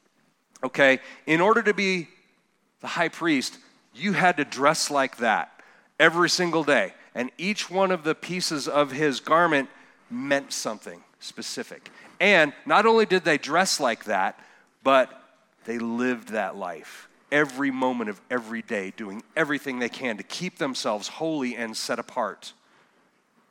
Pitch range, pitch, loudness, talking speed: 135-185 Hz, 155 Hz, -24 LUFS, 150 wpm